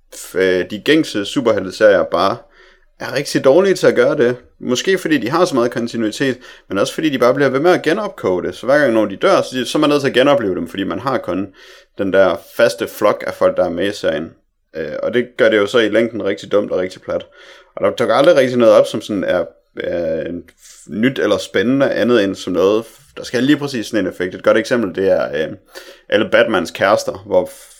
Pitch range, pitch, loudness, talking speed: 120-180 Hz, 135 Hz, -16 LUFS, 225 wpm